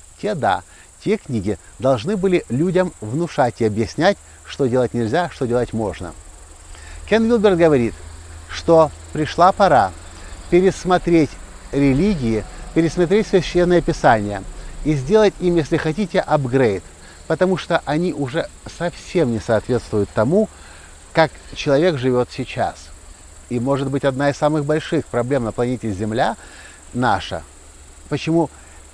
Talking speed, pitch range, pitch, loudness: 120 wpm, 100-170 Hz, 135 Hz, -19 LUFS